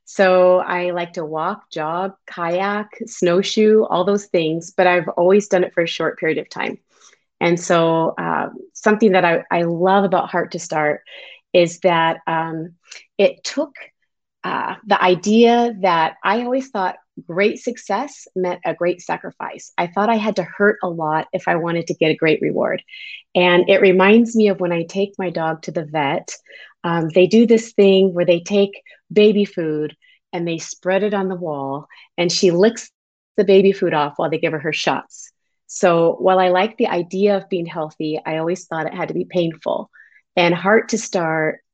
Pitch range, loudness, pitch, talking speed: 165-200 Hz, -18 LUFS, 180 Hz, 190 wpm